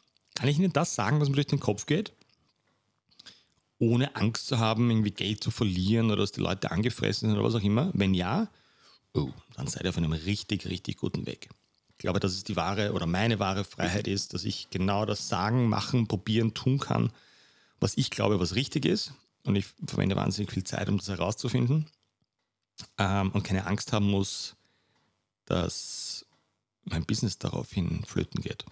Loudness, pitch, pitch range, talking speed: -29 LUFS, 105 Hz, 100-120 Hz, 180 wpm